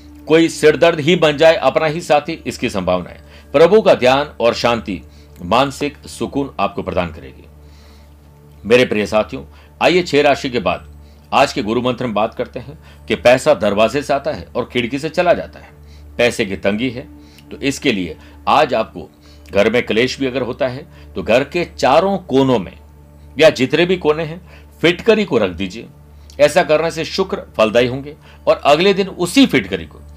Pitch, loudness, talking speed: 120 Hz, -15 LUFS, 185 wpm